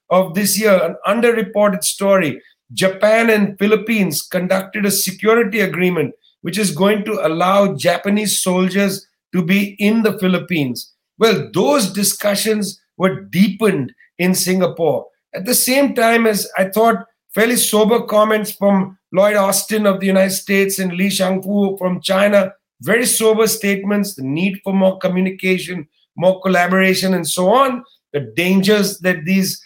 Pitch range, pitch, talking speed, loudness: 185-210 Hz, 195 Hz, 145 wpm, -16 LUFS